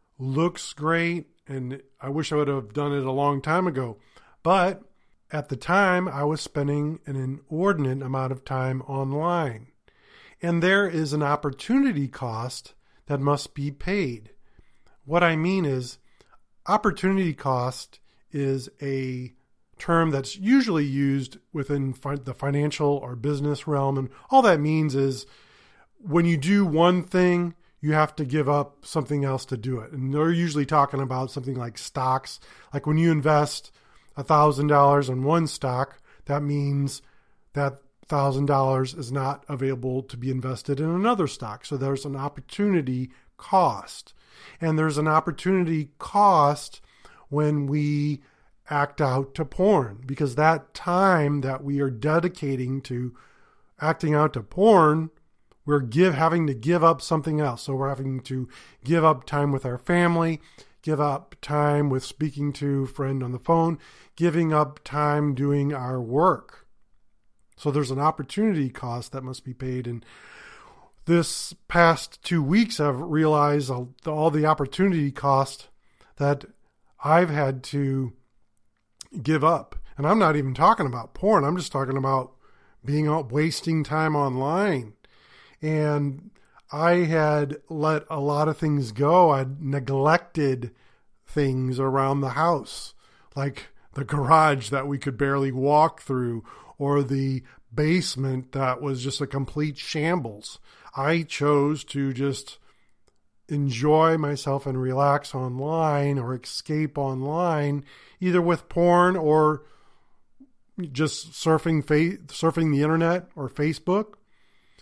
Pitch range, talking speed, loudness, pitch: 135-160 Hz, 140 wpm, -24 LUFS, 145 Hz